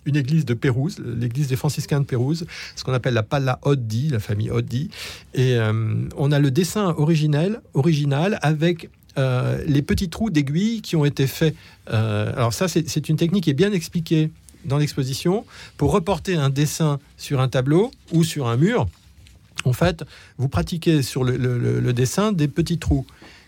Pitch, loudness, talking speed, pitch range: 145 Hz, -22 LUFS, 185 wpm, 125-165 Hz